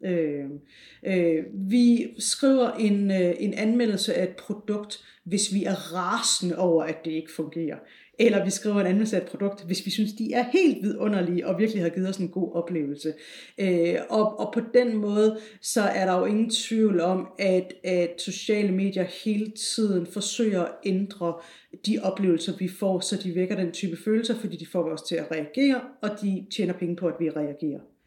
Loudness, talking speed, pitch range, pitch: -26 LUFS, 190 wpm, 175-215 Hz, 195 Hz